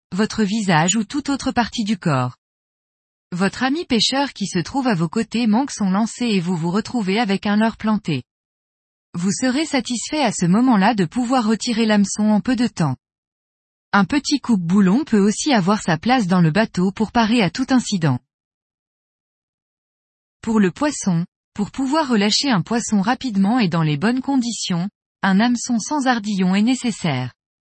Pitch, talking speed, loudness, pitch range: 215 Hz, 170 wpm, -19 LUFS, 180-240 Hz